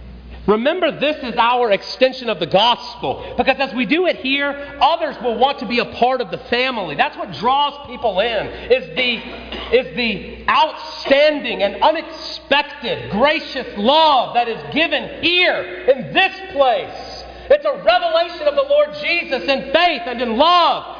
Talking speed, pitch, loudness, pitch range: 165 wpm, 280 Hz, -17 LUFS, 240-310 Hz